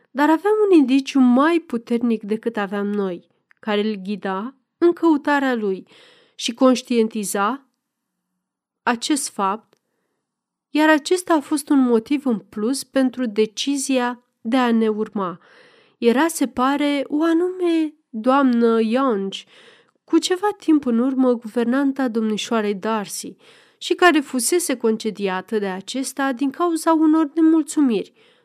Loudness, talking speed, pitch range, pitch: -20 LUFS, 120 wpm, 225-310 Hz, 260 Hz